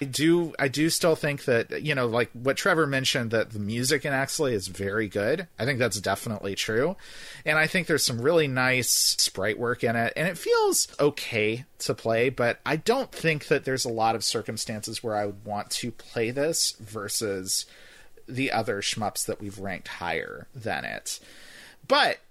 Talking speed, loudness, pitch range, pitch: 190 wpm, -26 LUFS, 110-145 Hz, 125 Hz